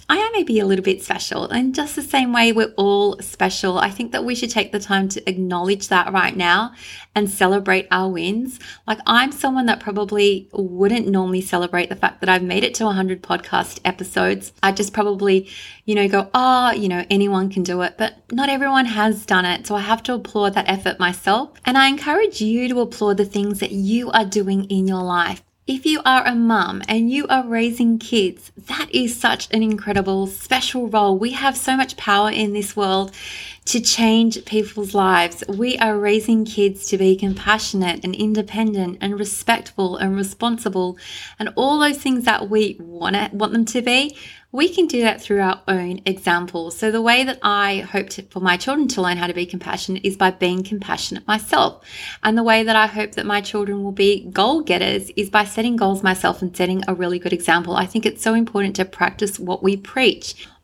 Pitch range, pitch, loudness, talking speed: 190-230 Hz, 205 Hz, -19 LUFS, 205 wpm